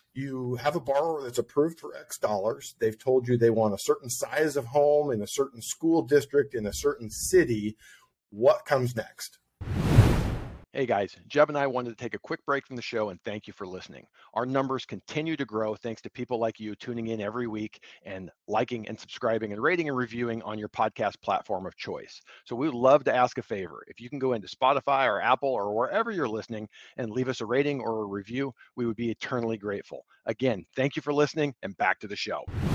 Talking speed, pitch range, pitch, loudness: 220 wpm, 110-140 Hz, 125 Hz, -28 LUFS